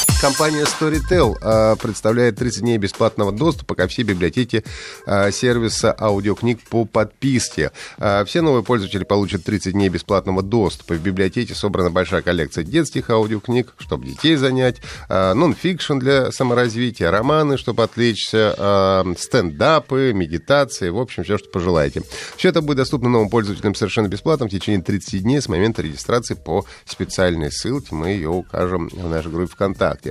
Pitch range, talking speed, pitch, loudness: 95-125 Hz, 140 wpm, 110 Hz, -19 LUFS